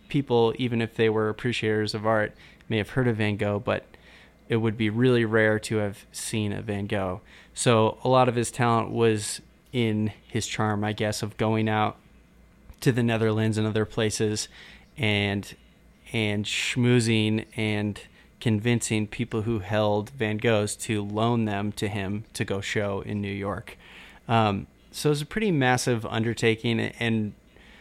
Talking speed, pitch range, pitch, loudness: 170 wpm, 105-115 Hz, 110 Hz, -26 LUFS